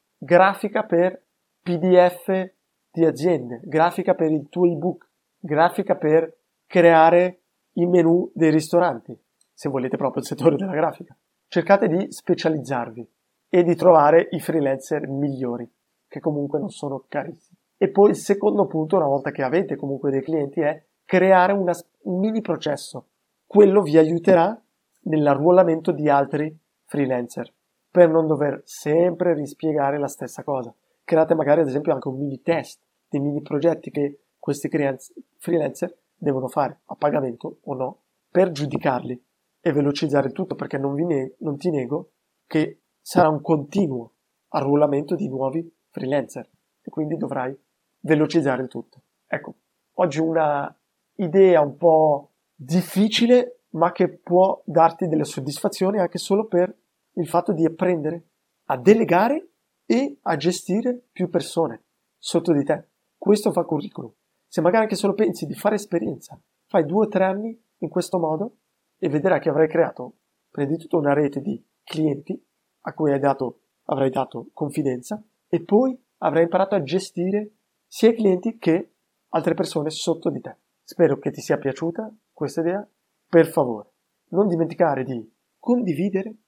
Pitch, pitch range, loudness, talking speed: 165 Hz, 145-185 Hz, -21 LUFS, 145 wpm